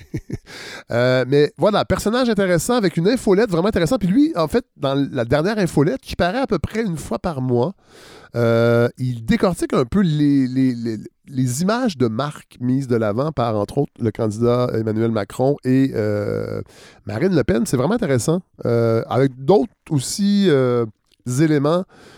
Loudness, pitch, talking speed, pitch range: -19 LUFS, 140 Hz, 170 wpm, 120-190 Hz